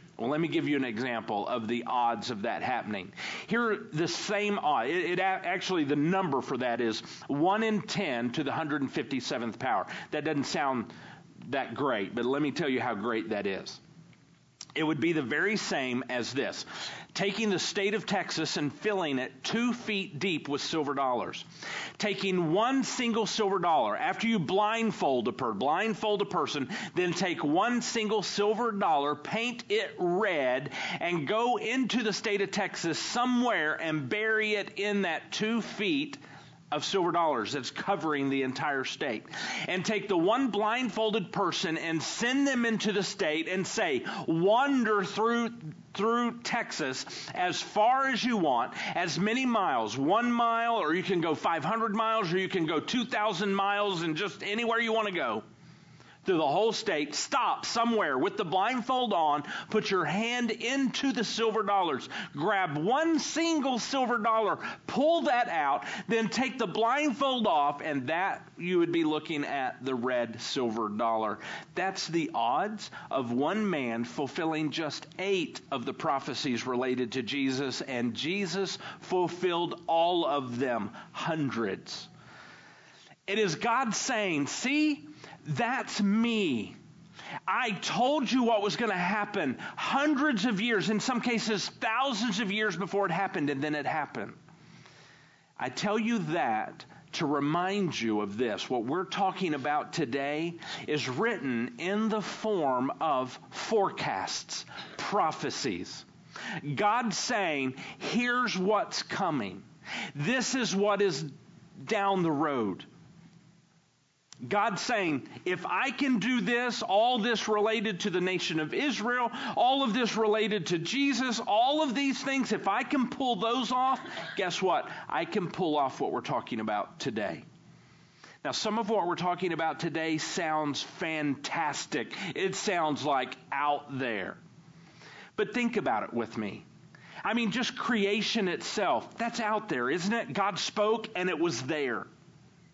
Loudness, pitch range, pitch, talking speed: -30 LUFS, 160-225 Hz, 200 Hz, 155 wpm